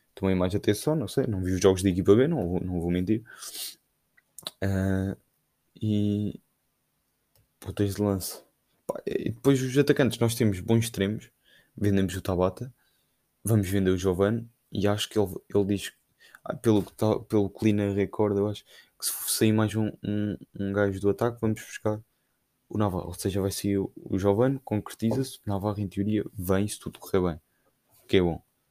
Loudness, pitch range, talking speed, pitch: -27 LUFS, 95-110 Hz, 175 wpm, 100 Hz